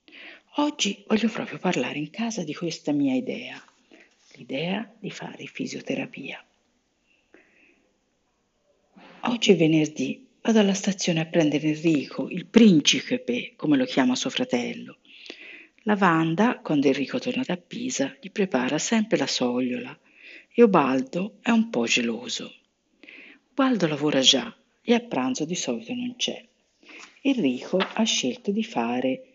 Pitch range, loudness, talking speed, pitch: 175-260 Hz, -24 LUFS, 130 wpm, 235 Hz